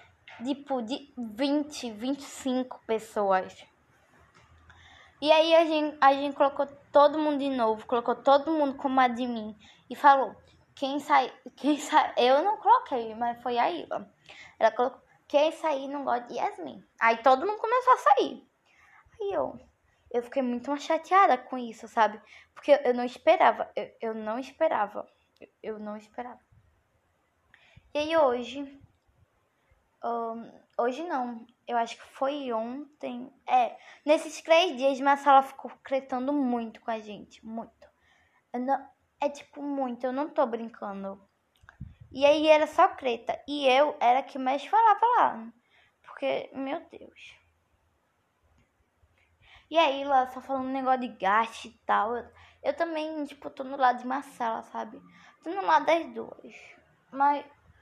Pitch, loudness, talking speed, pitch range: 270 Hz, -27 LUFS, 150 wpm, 245-295 Hz